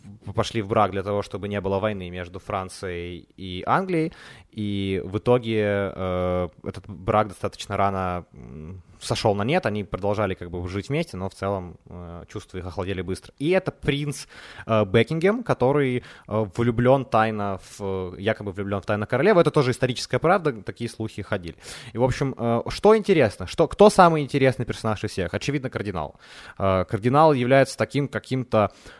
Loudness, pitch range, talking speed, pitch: -23 LUFS, 95-125 Hz, 165 wpm, 105 Hz